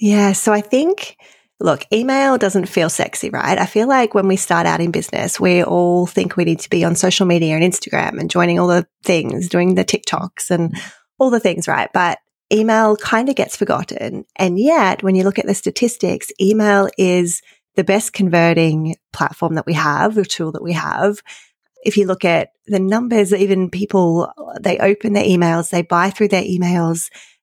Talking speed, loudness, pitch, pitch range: 195 wpm, -16 LUFS, 190 Hz, 175-210 Hz